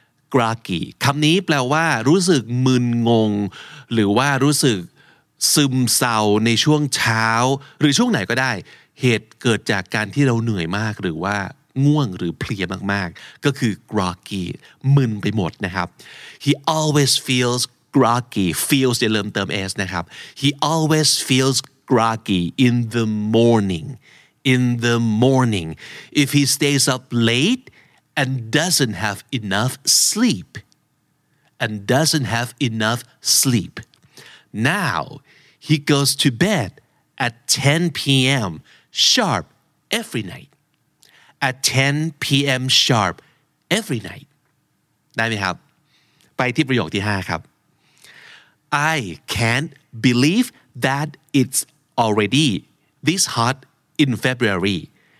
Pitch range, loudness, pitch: 110-145 Hz, -18 LUFS, 130 Hz